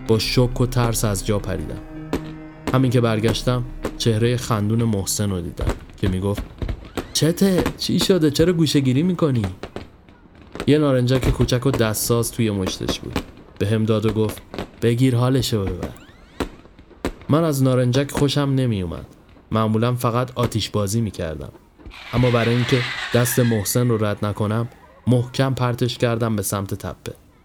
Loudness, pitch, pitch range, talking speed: -21 LUFS, 115 Hz, 105-130 Hz, 145 wpm